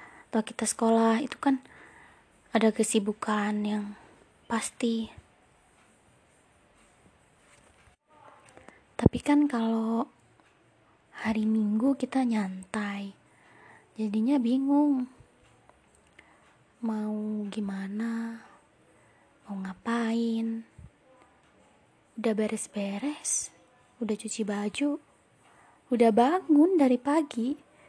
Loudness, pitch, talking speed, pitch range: -28 LUFS, 225 Hz, 65 wpm, 215-255 Hz